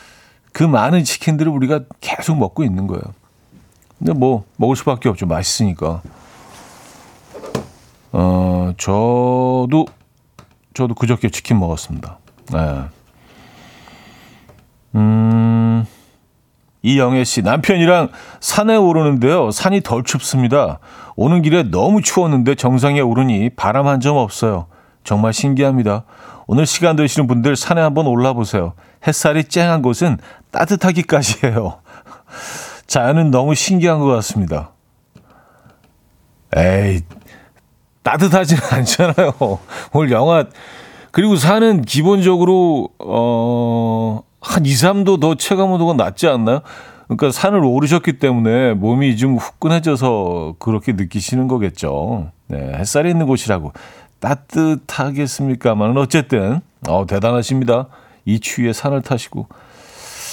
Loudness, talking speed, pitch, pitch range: -15 LUFS, 255 characters per minute, 130 Hz, 110-155 Hz